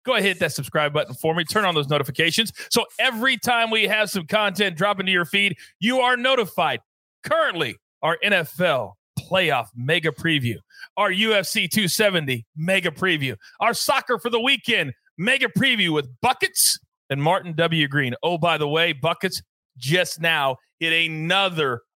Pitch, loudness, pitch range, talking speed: 180 Hz, -21 LUFS, 160-220 Hz, 165 wpm